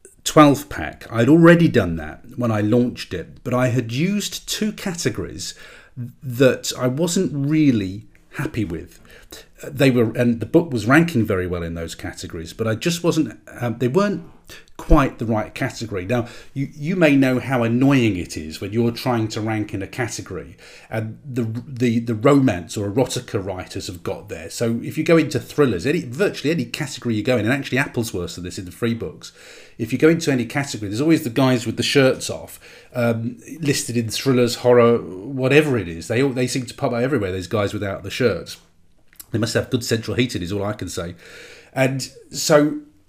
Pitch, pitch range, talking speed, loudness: 120 Hz, 110-140 Hz, 200 wpm, -20 LUFS